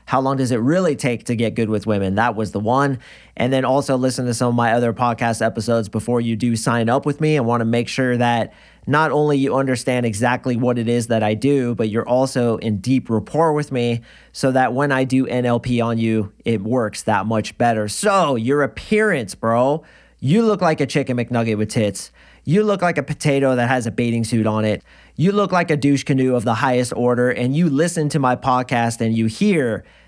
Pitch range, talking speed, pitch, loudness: 115-135 Hz, 225 wpm, 125 Hz, -19 LUFS